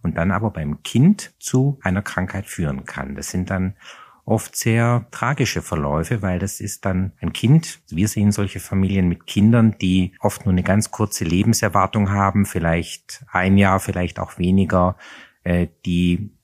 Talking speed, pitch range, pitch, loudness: 160 wpm, 90-105 Hz, 95 Hz, -20 LUFS